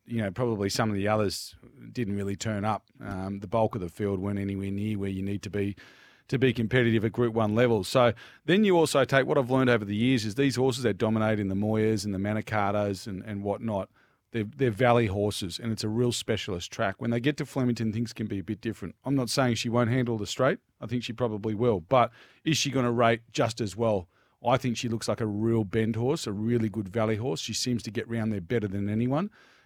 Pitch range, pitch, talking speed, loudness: 105-125 Hz, 115 Hz, 250 wpm, -28 LUFS